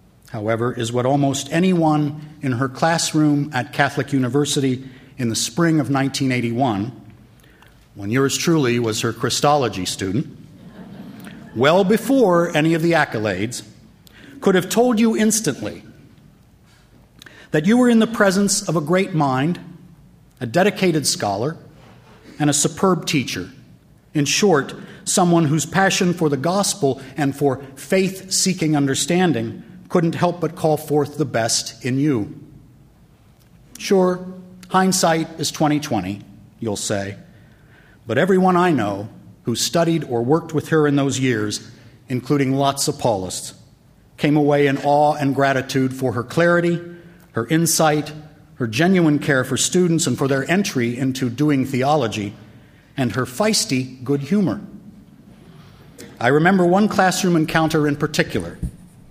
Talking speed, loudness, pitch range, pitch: 135 wpm, -19 LUFS, 130-175 Hz, 150 Hz